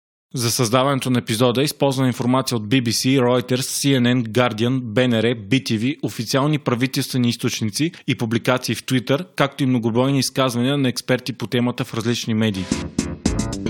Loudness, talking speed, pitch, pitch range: -20 LUFS, 135 wpm, 125 Hz, 120-135 Hz